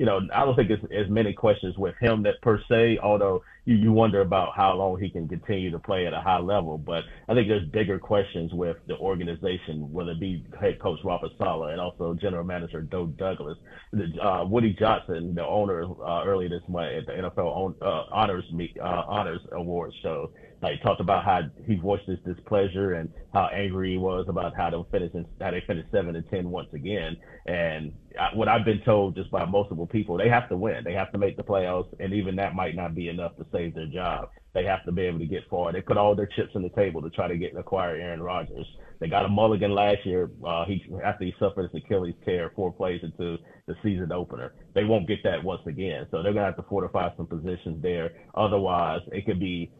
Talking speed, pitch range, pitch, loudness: 230 wpm, 85-100 Hz, 95 Hz, -27 LUFS